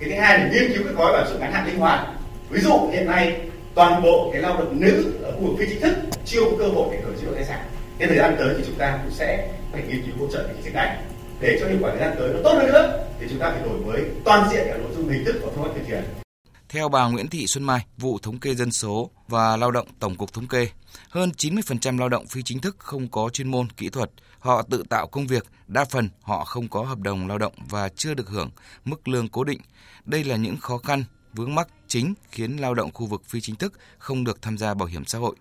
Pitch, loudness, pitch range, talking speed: 125 Hz, -23 LUFS, 110-145 Hz, 280 wpm